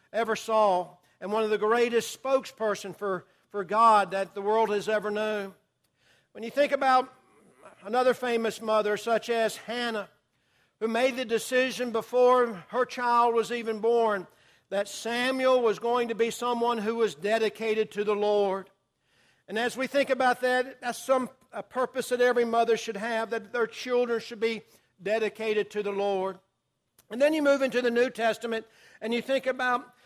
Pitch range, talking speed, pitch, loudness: 210-245 Hz, 170 wpm, 230 Hz, -27 LUFS